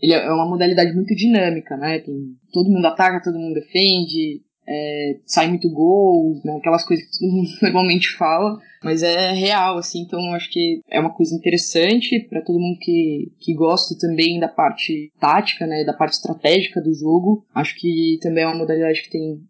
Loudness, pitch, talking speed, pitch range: -18 LUFS, 170 Hz, 185 wpm, 160-185 Hz